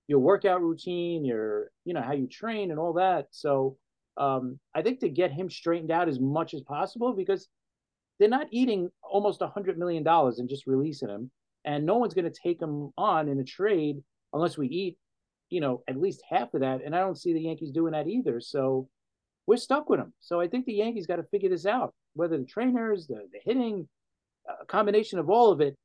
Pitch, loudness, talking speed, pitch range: 170 Hz, -28 LUFS, 220 wpm, 140-205 Hz